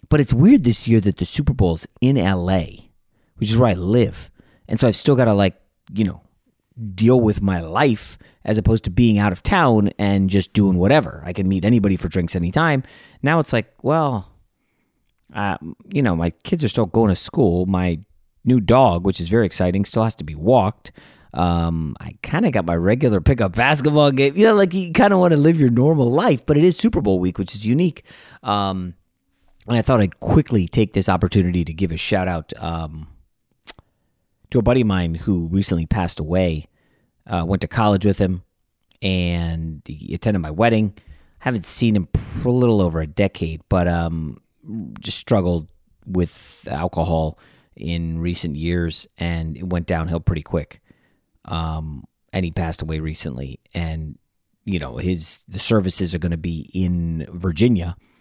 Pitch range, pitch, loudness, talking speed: 85-115 Hz, 95 Hz, -19 LUFS, 190 wpm